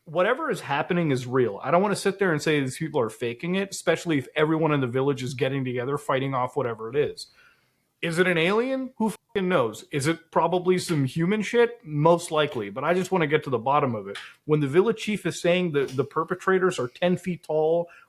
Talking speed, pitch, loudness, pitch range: 235 wpm, 165 Hz, -25 LUFS, 140-185 Hz